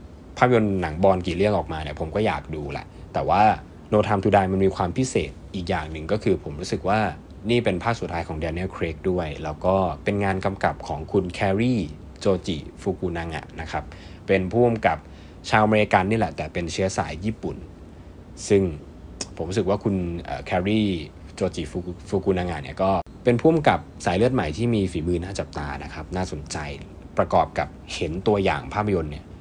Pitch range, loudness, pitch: 80-100 Hz, -24 LUFS, 90 Hz